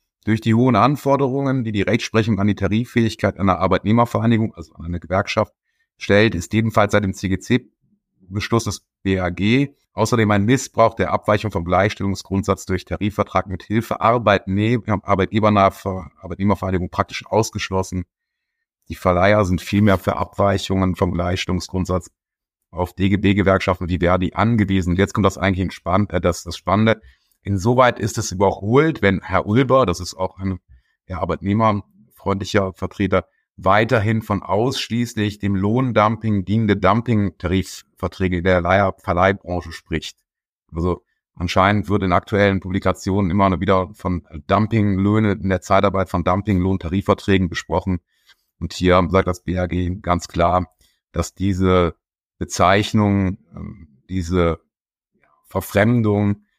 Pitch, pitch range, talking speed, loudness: 100 Hz, 90-105 Hz, 120 wpm, -19 LUFS